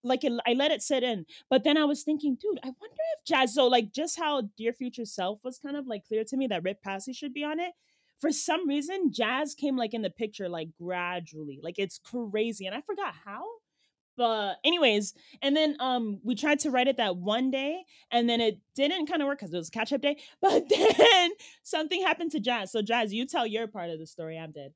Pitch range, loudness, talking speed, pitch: 215-300 Hz, -28 LUFS, 240 wpm, 255 Hz